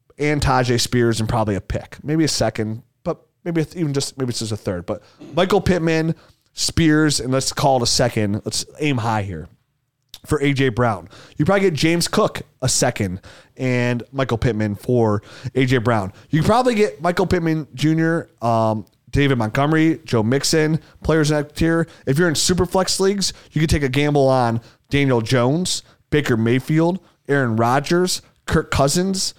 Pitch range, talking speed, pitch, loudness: 120-160 Hz, 170 wpm, 135 Hz, -19 LUFS